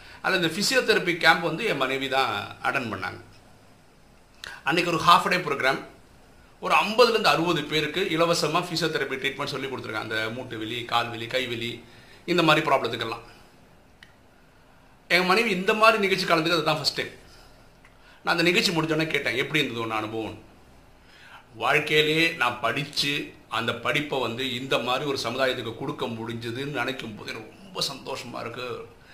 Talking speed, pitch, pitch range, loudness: 135 wpm, 135 Hz, 115-160 Hz, -24 LUFS